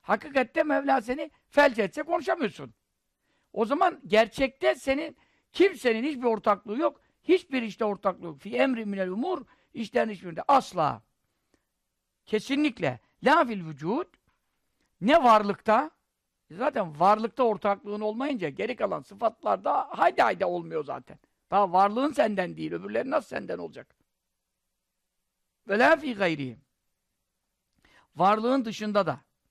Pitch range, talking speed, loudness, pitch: 200-285 Hz, 120 wpm, -26 LUFS, 230 Hz